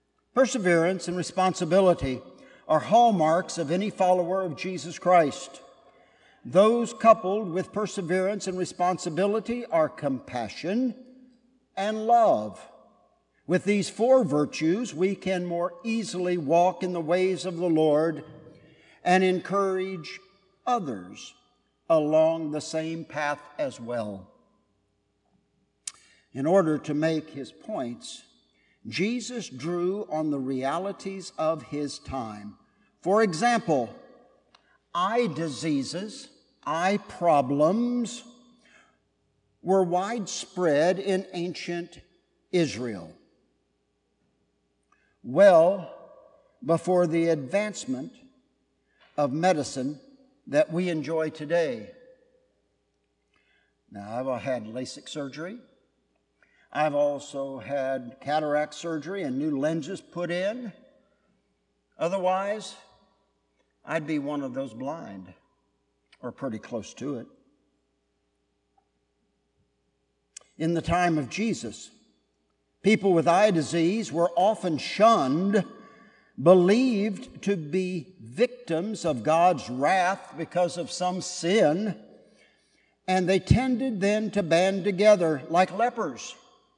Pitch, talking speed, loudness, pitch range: 180 Hz, 95 wpm, -26 LUFS, 155-205 Hz